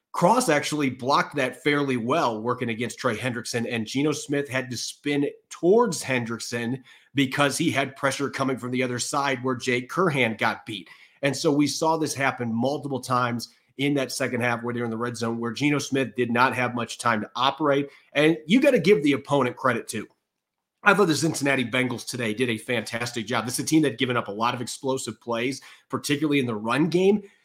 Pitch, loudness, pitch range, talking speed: 130 Hz, -24 LUFS, 120-145 Hz, 210 wpm